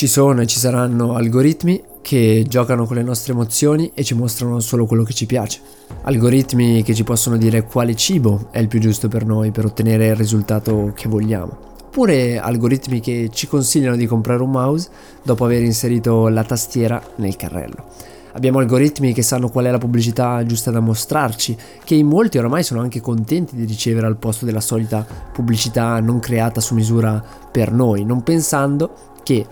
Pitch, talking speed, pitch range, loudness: 120 Hz, 180 wpm, 115-125 Hz, -17 LUFS